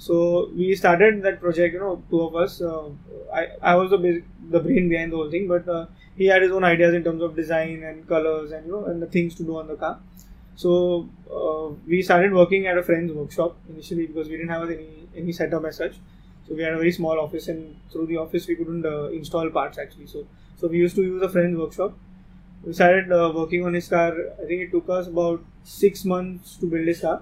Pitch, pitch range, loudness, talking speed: 170 Hz, 160-180 Hz, -22 LUFS, 240 wpm